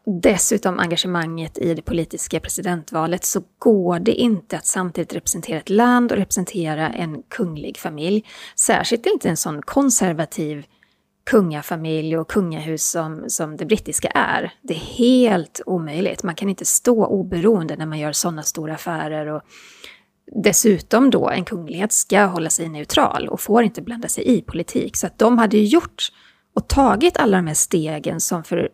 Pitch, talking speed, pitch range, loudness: 180 Hz, 165 wpm, 160-215 Hz, -19 LUFS